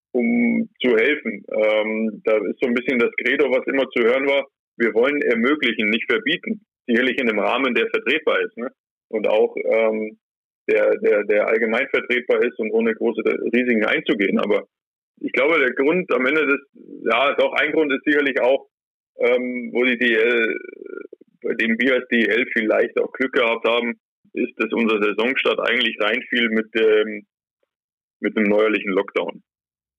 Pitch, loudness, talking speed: 135 Hz, -19 LUFS, 170 wpm